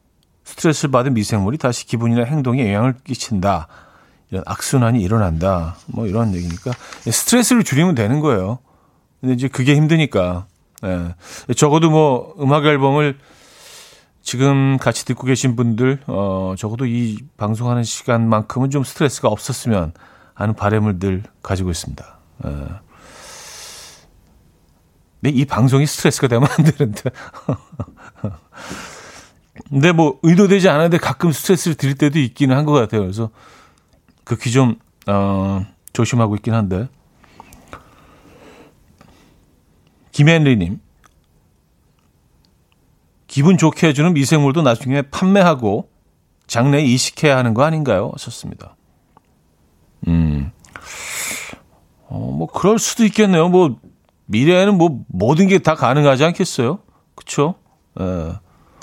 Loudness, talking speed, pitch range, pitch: -16 LUFS, 260 characters per minute, 100-150 Hz, 125 Hz